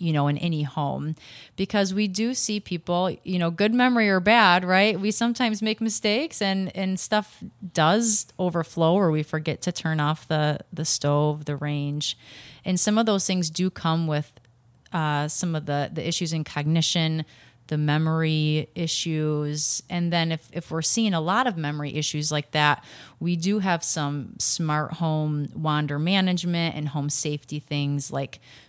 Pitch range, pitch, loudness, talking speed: 150-185 Hz, 160 Hz, -23 LUFS, 170 wpm